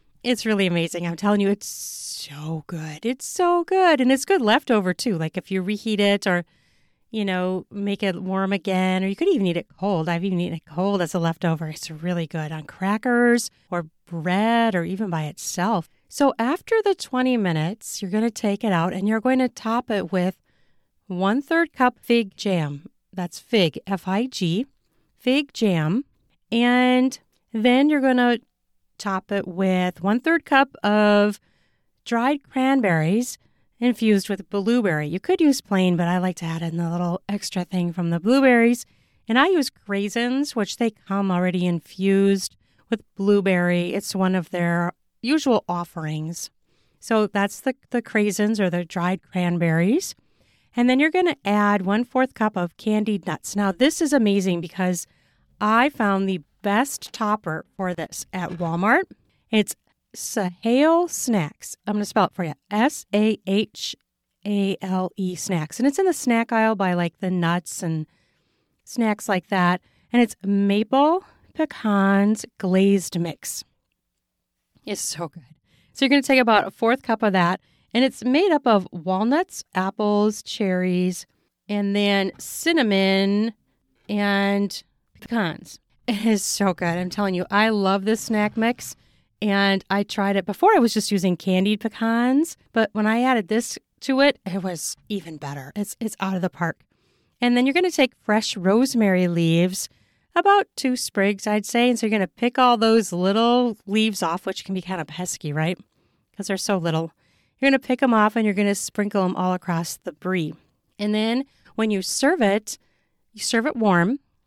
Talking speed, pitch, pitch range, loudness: 175 wpm, 200 Hz, 180-235 Hz, -22 LUFS